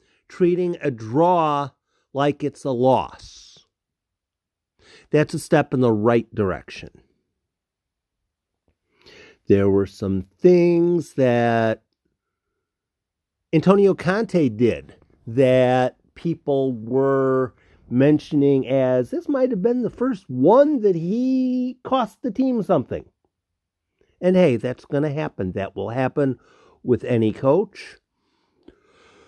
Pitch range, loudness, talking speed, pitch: 105-180 Hz, -20 LUFS, 105 wpm, 135 Hz